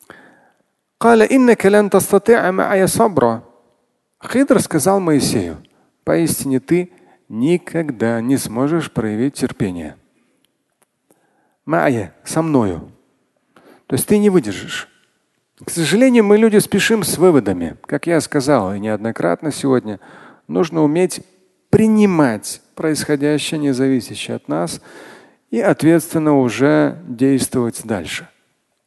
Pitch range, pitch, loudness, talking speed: 130-195 Hz, 155 Hz, -16 LUFS, 100 wpm